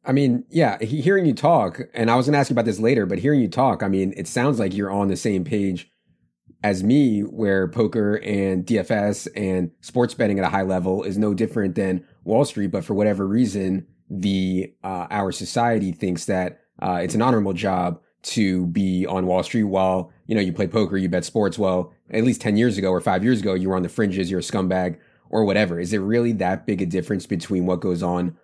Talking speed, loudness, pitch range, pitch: 230 wpm, -22 LUFS, 95-110 Hz, 95 Hz